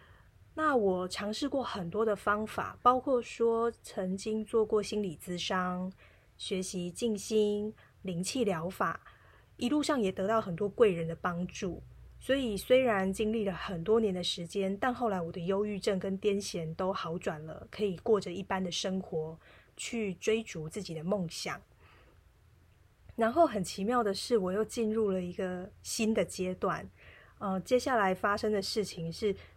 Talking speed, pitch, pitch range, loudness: 235 characters per minute, 200 Hz, 180-220 Hz, -32 LUFS